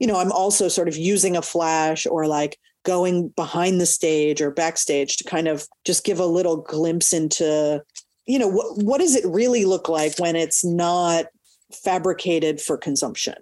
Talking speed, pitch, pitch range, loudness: 185 wpm, 170 Hz, 160-185 Hz, -21 LUFS